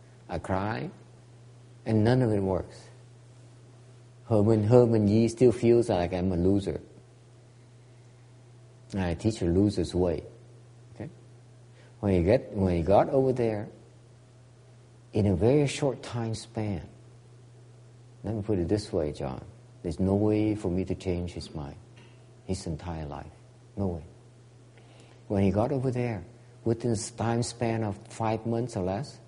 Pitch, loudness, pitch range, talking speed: 120 Hz, -28 LUFS, 100-120 Hz, 150 wpm